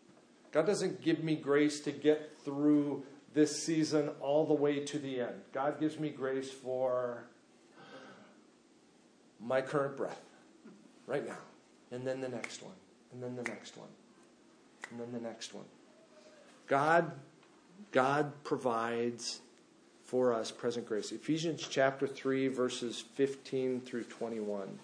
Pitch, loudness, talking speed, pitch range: 135 Hz, -35 LUFS, 135 wpm, 125-150 Hz